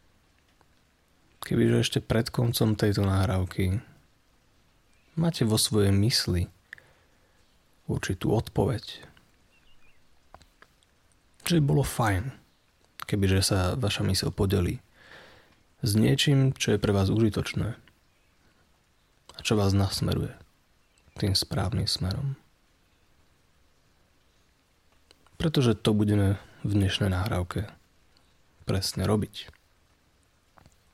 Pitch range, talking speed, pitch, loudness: 90-110 Hz, 85 wpm, 100 Hz, -26 LUFS